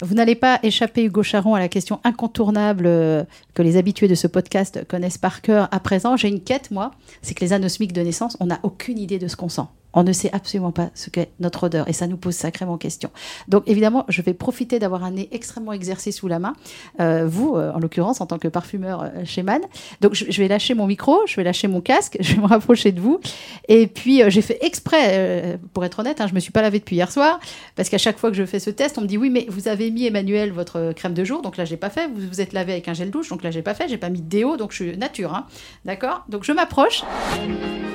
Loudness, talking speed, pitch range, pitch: -20 LUFS, 265 wpm, 180-225 Hz, 200 Hz